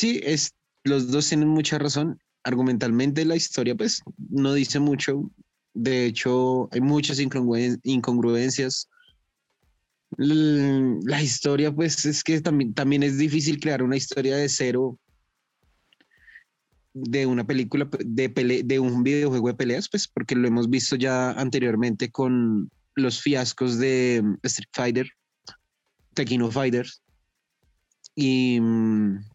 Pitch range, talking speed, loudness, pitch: 125-145 Hz, 125 wpm, -23 LUFS, 130 Hz